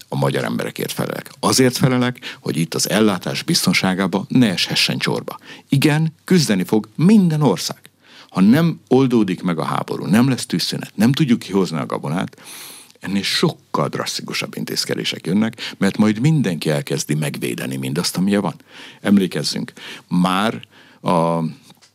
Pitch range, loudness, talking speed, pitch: 85-130 Hz, -18 LUFS, 135 wpm, 100 Hz